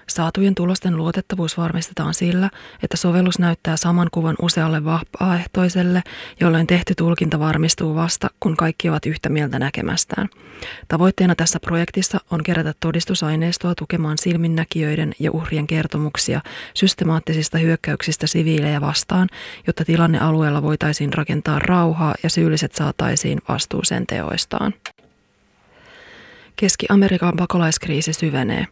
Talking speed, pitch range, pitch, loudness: 110 wpm, 160-180 Hz, 165 Hz, -19 LUFS